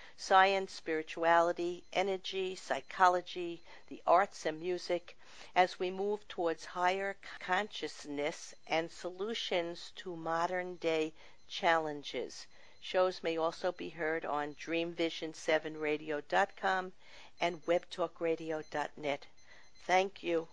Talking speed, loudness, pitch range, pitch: 90 wpm, -34 LUFS, 160-185 Hz, 170 Hz